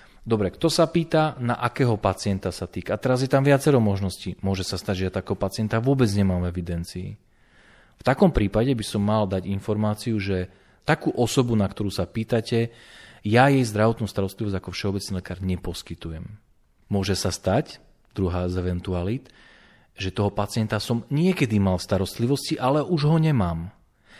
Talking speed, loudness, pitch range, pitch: 165 wpm, -24 LUFS, 95-120 Hz, 105 Hz